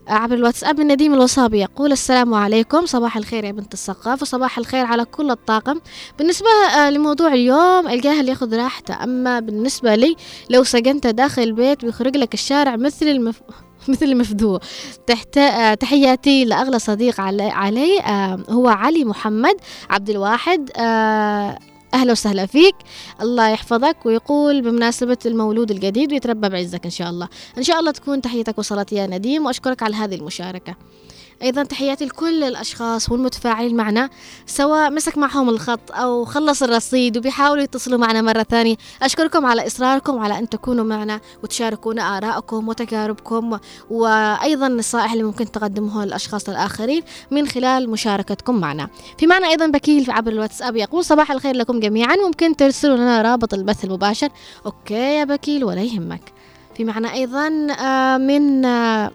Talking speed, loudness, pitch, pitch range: 140 wpm, -17 LUFS, 240 Hz, 220-280 Hz